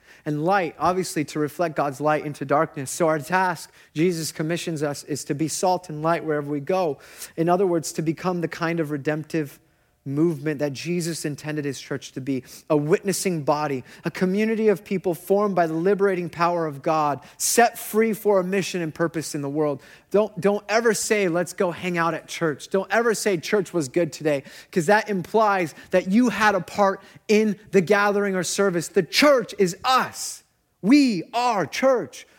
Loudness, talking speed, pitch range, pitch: -23 LUFS, 190 wpm, 155-200 Hz, 175 Hz